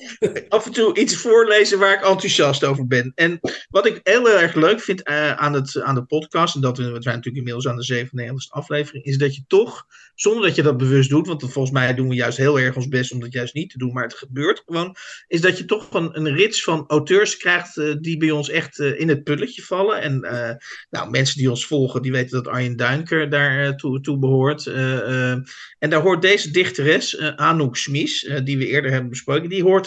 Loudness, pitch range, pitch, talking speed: -19 LUFS, 130-170 Hz, 145 Hz, 235 wpm